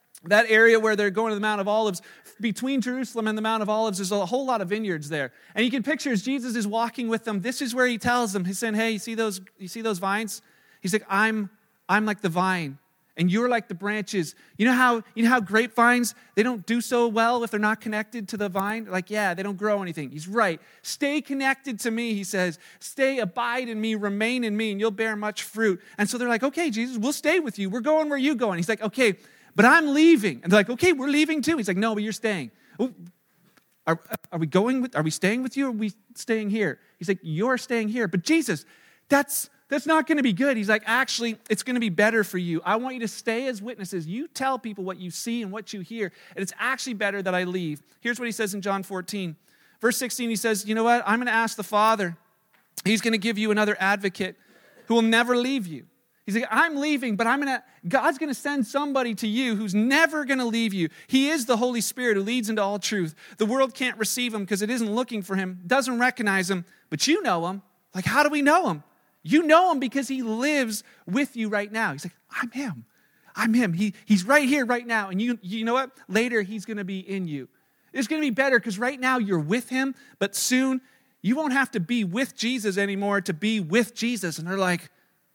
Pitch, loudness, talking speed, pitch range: 225 Hz, -24 LUFS, 245 wpm, 200-250 Hz